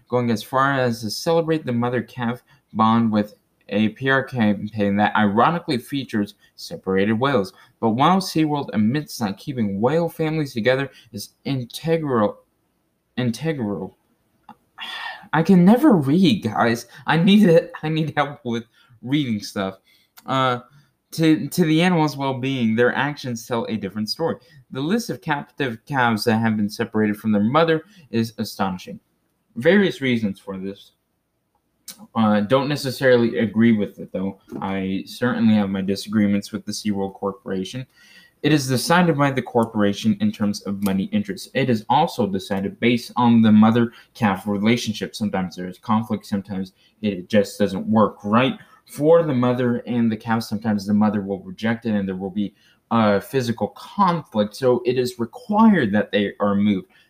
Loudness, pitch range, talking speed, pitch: -21 LUFS, 105-135 Hz, 155 wpm, 115 Hz